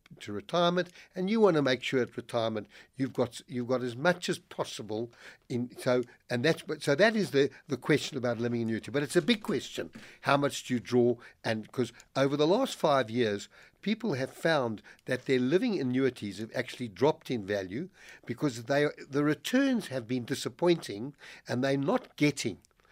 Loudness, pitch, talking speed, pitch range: -30 LUFS, 130 Hz, 190 wpm, 120-155 Hz